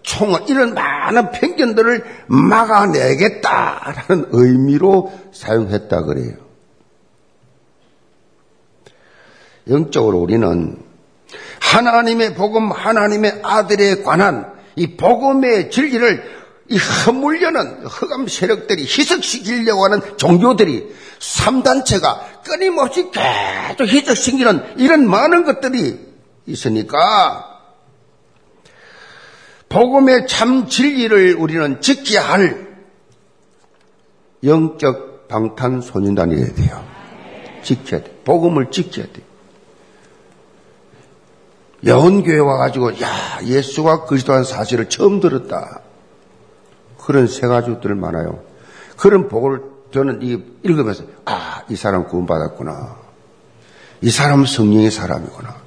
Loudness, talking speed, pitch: -15 LUFS, 225 characters per minute, 195 Hz